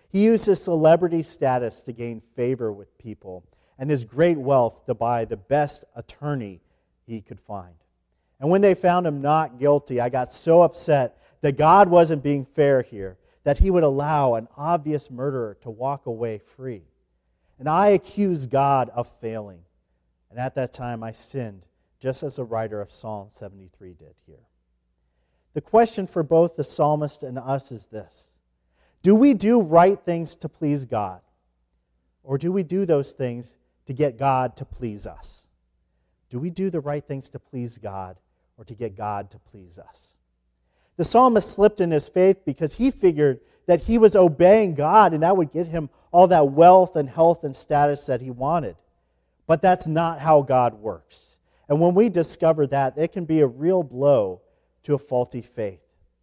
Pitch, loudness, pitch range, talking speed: 135 Hz, -21 LUFS, 105-165 Hz, 180 wpm